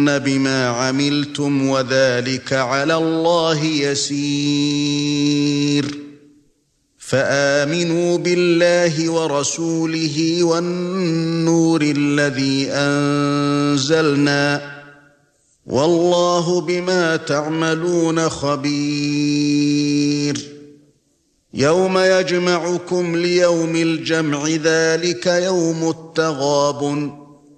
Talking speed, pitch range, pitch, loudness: 50 wpm, 145-165 Hz, 145 Hz, -17 LUFS